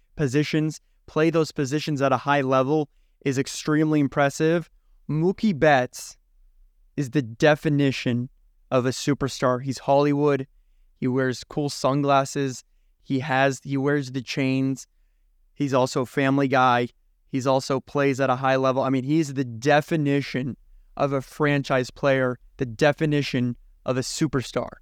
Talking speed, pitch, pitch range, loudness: 135 wpm, 135 Hz, 125-145 Hz, -23 LUFS